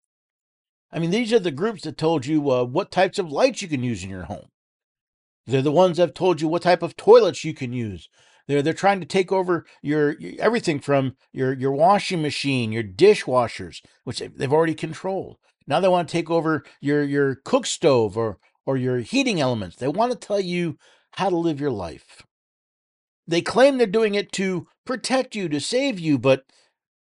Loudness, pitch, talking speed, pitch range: -22 LUFS, 165 Hz, 200 wpm, 135-190 Hz